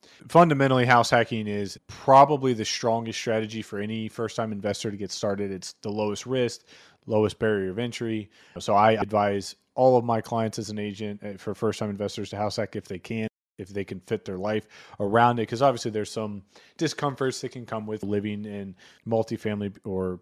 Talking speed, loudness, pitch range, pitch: 195 wpm, -26 LUFS, 105-120 Hz, 110 Hz